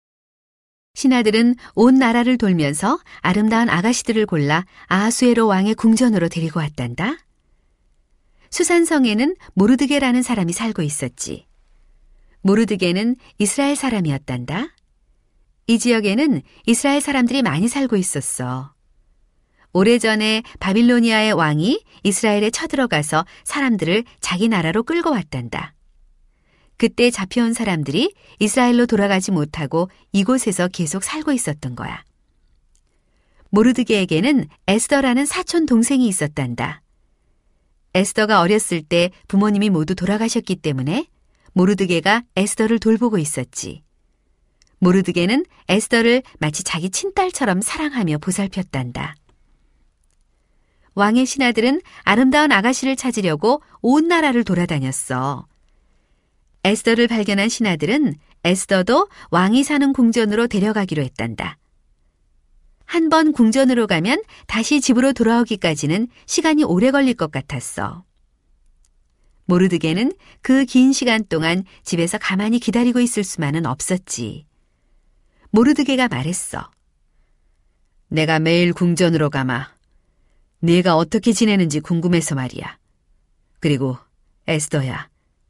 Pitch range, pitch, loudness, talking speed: 150-240 Hz, 195 Hz, -18 LUFS, 285 characters per minute